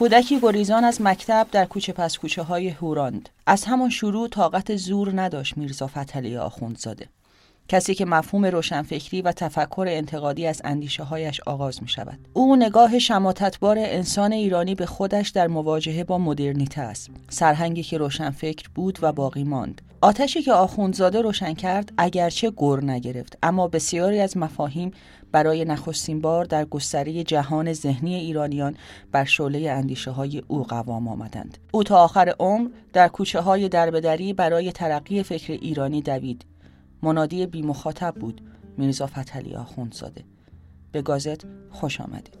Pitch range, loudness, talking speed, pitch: 140-190 Hz, -22 LUFS, 145 wpm, 160 Hz